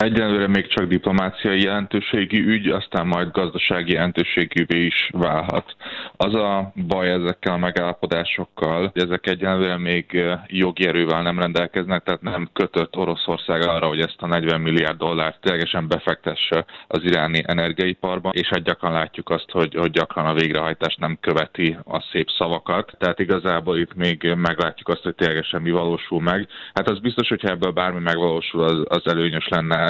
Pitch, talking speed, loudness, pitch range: 85 Hz, 155 wpm, -21 LUFS, 85-95 Hz